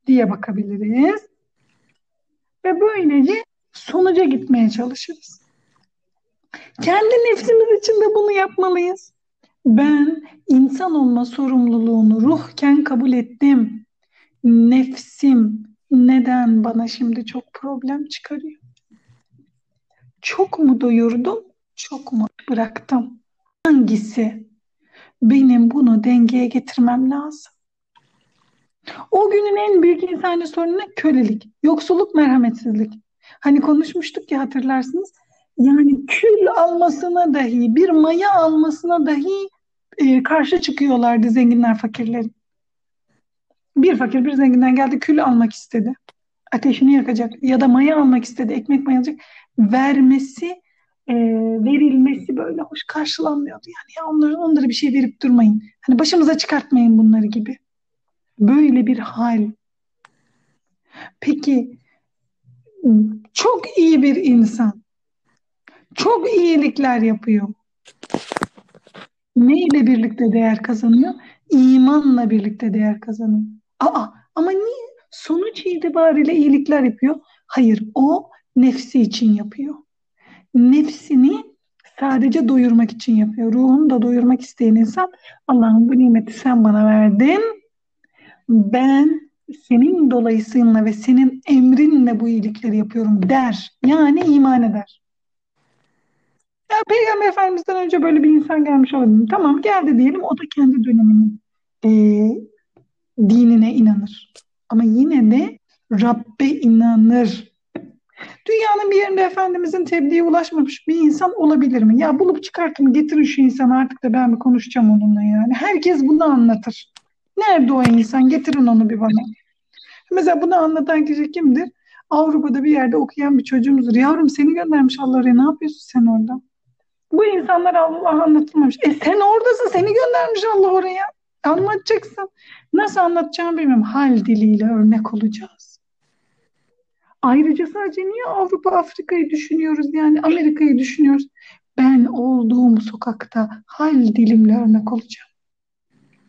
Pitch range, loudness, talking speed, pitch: 235-320 Hz, -16 LUFS, 115 wpm, 270 Hz